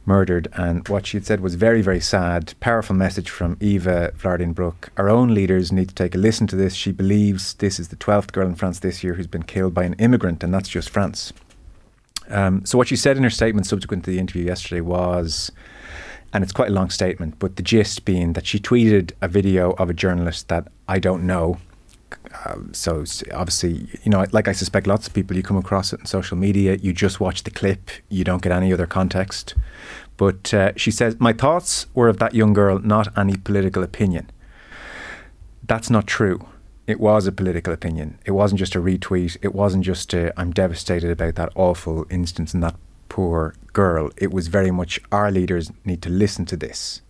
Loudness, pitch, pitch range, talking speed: -20 LUFS, 95 Hz, 90-100 Hz, 210 wpm